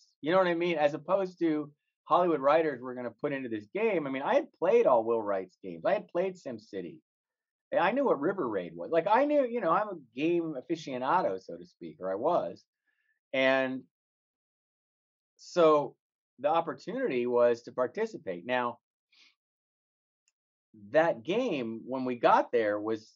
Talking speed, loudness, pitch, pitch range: 170 wpm, -29 LUFS, 145 Hz, 120-175 Hz